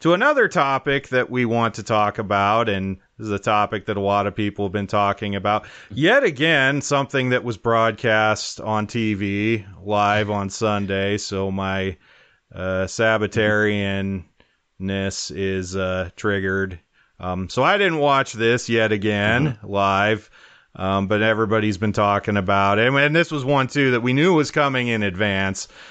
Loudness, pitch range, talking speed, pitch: -20 LUFS, 100-115 Hz, 160 wpm, 105 Hz